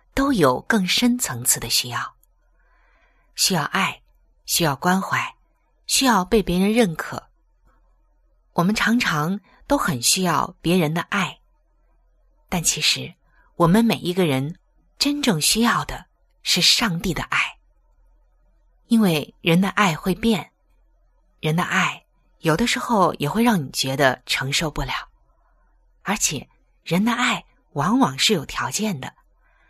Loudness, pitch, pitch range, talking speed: -20 LUFS, 180 Hz, 150-230 Hz, 180 characters per minute